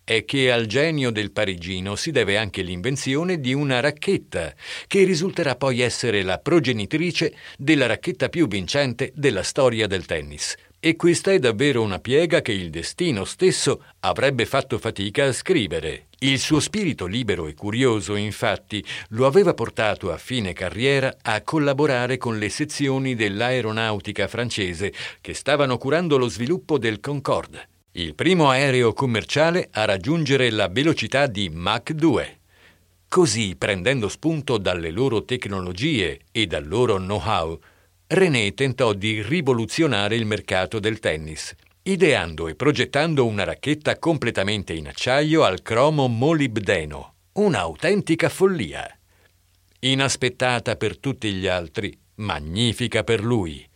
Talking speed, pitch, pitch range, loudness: 135 wpm, 120 Hz, 100-145 Hz, -22 LUFS